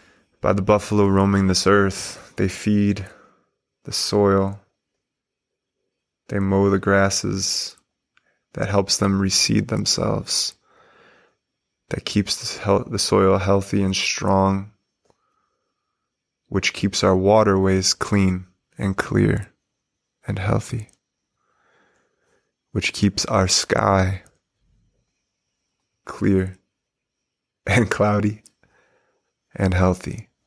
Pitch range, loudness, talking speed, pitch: 95-105 Hz, -20 LUFS, 85 wpm, 100 Hz